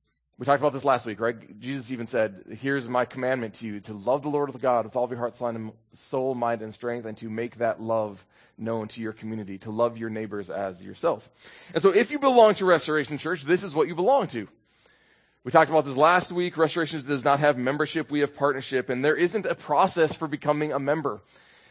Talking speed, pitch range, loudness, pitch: 225 wpm, 115-150 Hz, -25 LUFS, 130 Hz